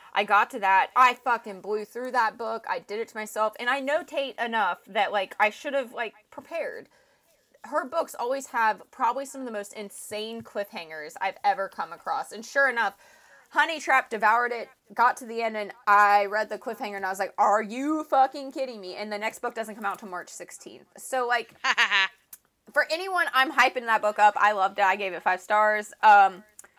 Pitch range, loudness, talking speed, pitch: 205-260 Hz, -25 LUFS, 210 wpm, 220 Hz